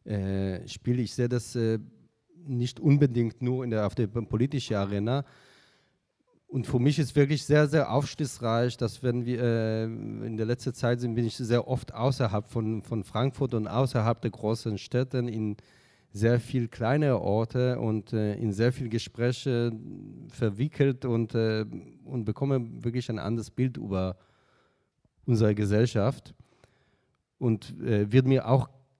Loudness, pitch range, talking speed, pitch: -28 LUFS, 110-130 Hz, 150 wpm, 120 Hz